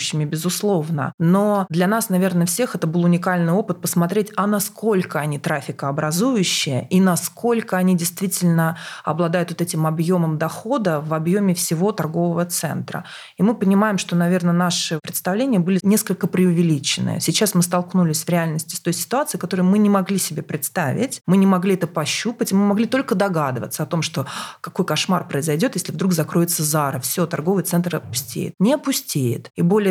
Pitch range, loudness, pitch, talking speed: 165-195 Hz, -20 LUFS, 175 Hz, 160 wpm